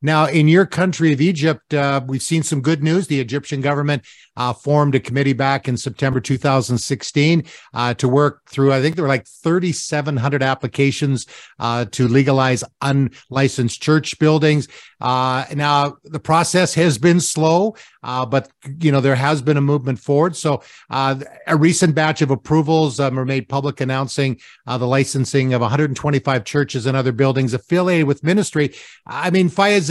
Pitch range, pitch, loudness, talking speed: 135-155 Hz, 140 Hz, -18 LUFS, 170 wpm